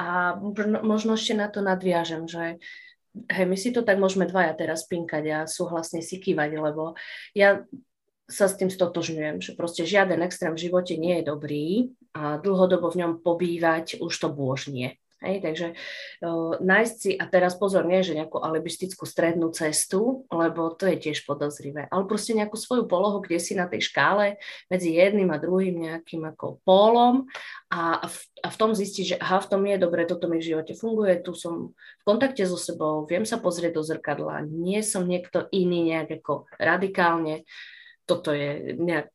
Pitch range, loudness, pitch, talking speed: 165-195 Hz, -25 LUFS, 175 Hz, 180 wpm